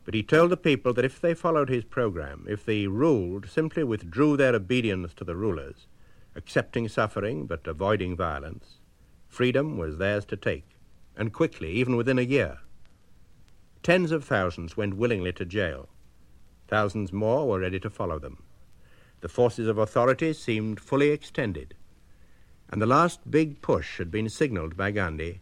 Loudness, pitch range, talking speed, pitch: -27 LUFS, 95-135 Hz, 160 wpm, 110 Hz